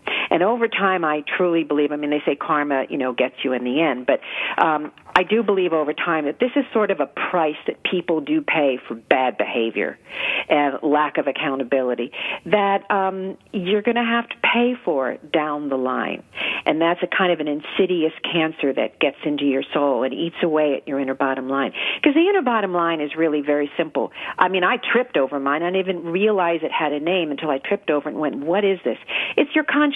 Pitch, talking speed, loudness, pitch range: 160 Hz, 225 wpm, -21 LUFS, 145-190 Hz